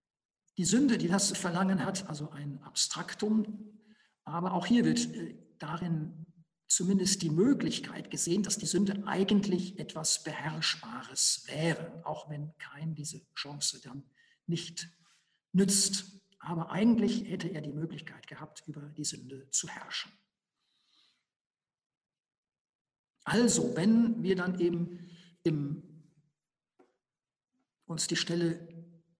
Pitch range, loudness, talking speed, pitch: 155-195 Hz, -31 LUFS, 110 wpm, 170 Hz